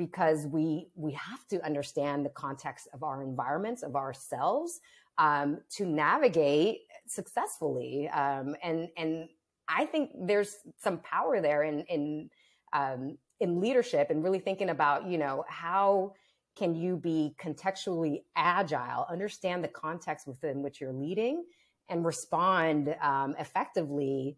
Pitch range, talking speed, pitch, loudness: 145-195 Hz, 135 wpm, 160 Hz, -32 LUFS